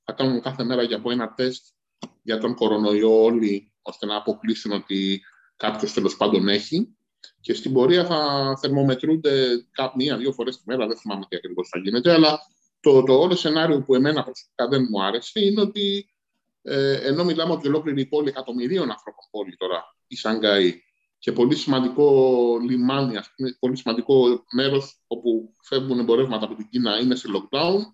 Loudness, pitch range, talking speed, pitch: -22 LUFS, 115-145 Hz, 170 wpm, 130 Hz